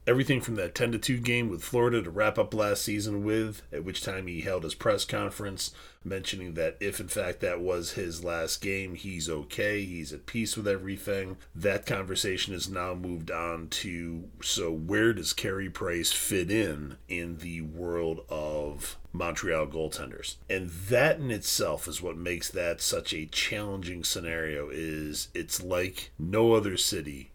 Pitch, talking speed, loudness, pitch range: 90 Hz, 170 wpm, -30 LUFS, 80-105 Hz